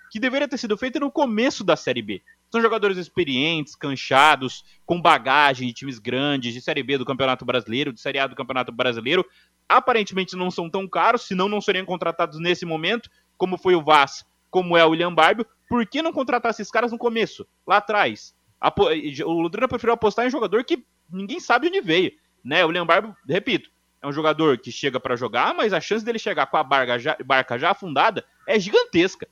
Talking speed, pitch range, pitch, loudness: 205 wpm, 140-230 Hz, 180 Hz, -21 LUFS